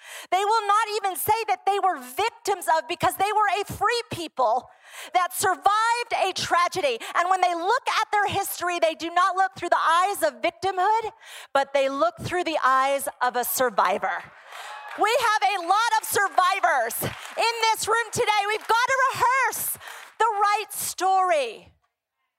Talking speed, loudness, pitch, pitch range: 165 wpm, -23 LUFS, 385 Hz, 345-430 Hz